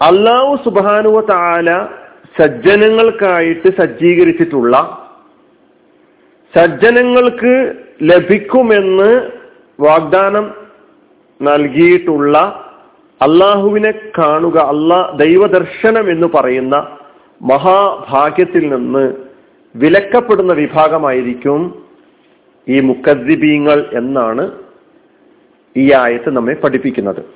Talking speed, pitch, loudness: 55 wpm, 200 Hz, -11 LUFS